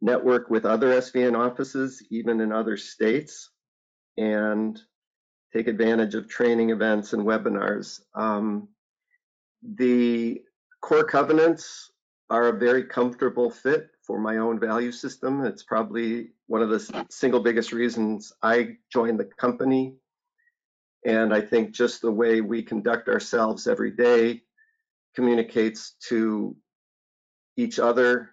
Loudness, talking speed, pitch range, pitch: -24 LUFS, 125 wpm, 110-130 Hz, 120 Hz